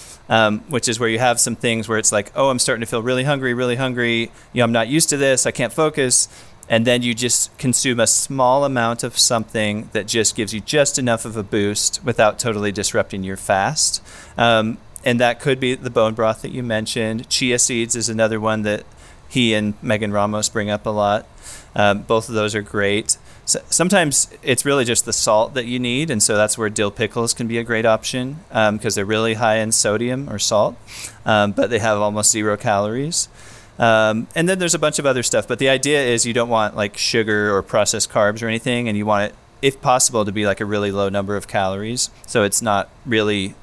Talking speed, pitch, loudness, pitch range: 225 wpm, 115 Hz, -18 LUFS, 105-125 Hz